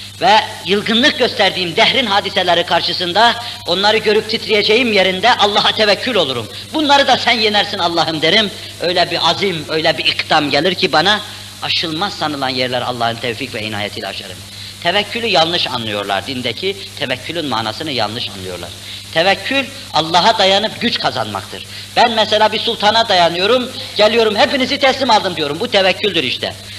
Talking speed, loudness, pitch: 140 wpm, -14 LUFS, 175 Hz